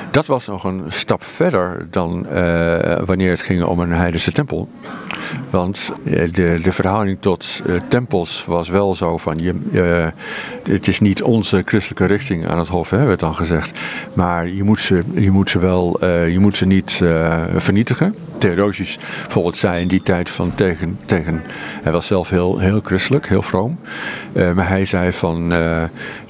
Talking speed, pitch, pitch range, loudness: 185 wpm, 90 Hz, 85-100 Hz, -17 LUFS